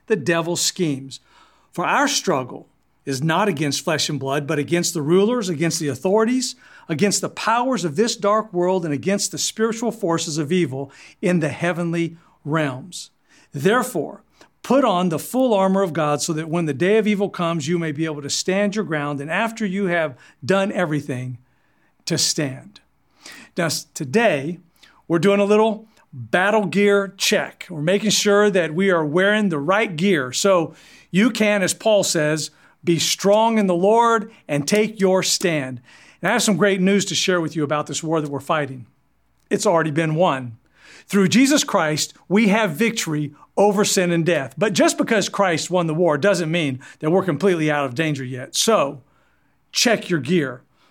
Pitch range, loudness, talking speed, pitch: 155-205 Hz, -20 LUFS, 180 wpm, 180 Hz